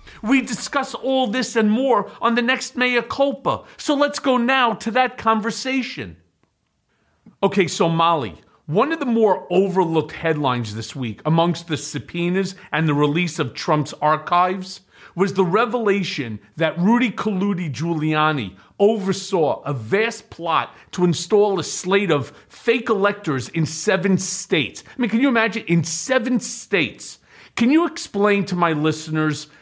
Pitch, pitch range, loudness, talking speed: 195 Hz, 160-235 Hz, -20 LUFS, 150 wpm